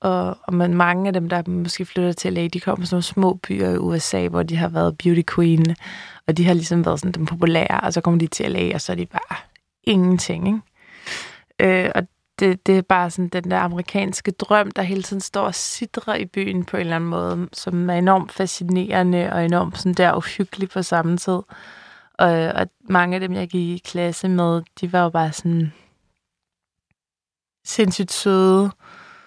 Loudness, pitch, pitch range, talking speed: -20 LUFS, 180 Hz, 170-190 Hz, 195 wpm